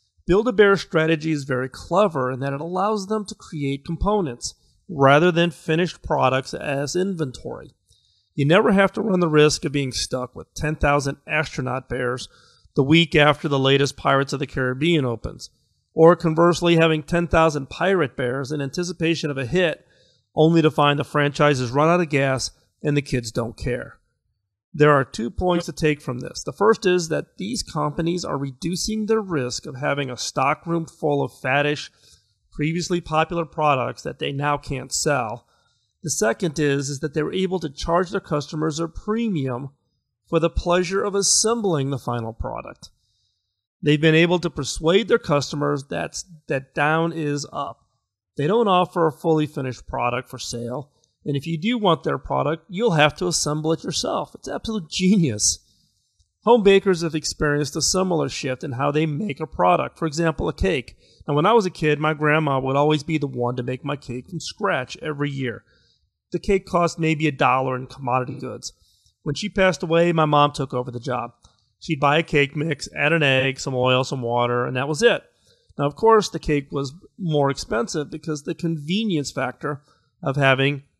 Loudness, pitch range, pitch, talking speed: -21 LUFS, 130-170 Hz, 150 Hz, 185 wpm